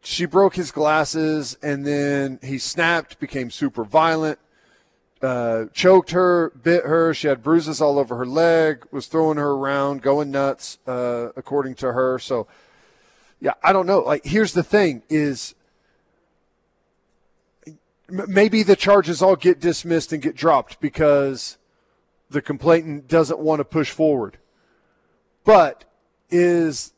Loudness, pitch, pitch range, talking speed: -19 LUFS, 155 Hz, 140-170 Hz, 140 wpm